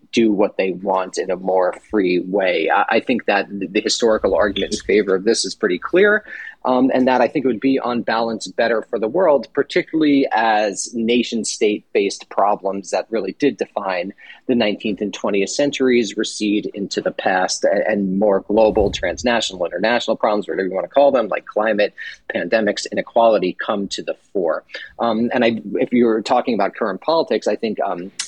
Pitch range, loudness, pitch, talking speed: 105-135 Hz, -18 LUFS, 120 Hz, 185 wpm